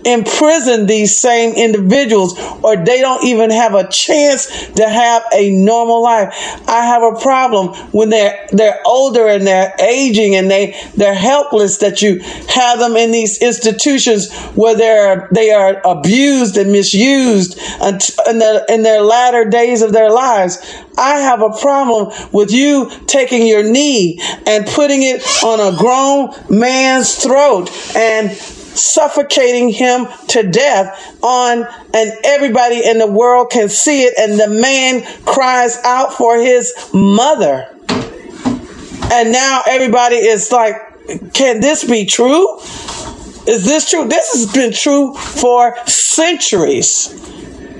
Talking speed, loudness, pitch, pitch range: 140 wpm, -11 LUFS, 235 Hz, 215-260 Hz